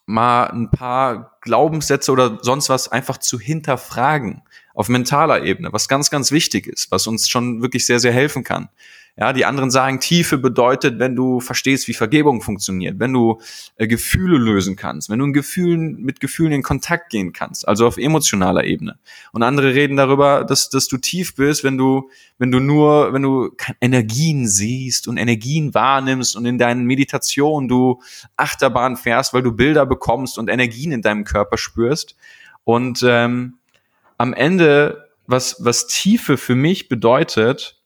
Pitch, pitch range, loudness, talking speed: 130 Hz, 120-140 Hz, -17 LUFS, 165 wpm